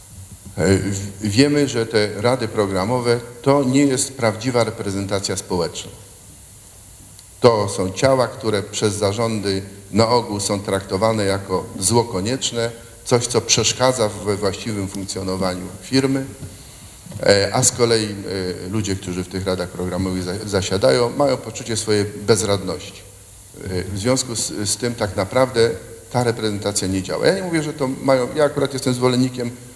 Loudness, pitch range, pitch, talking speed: -20 LUFS, 100-120 Hz, 105 Hz, 130 wpm